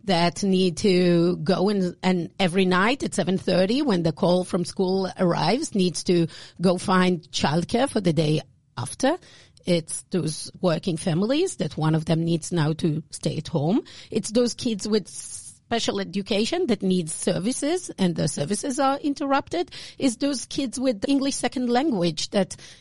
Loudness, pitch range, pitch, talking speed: -24 LUFS, 170-235 Hz, 185 Hz, 160 wpm